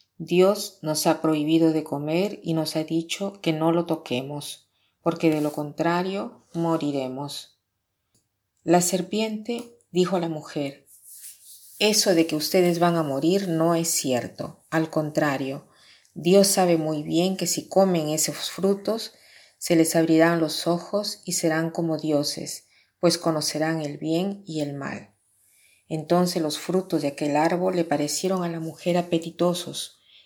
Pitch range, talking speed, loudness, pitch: 150-175 Hz, 145 wpm, -24 LUFS, 165 Hz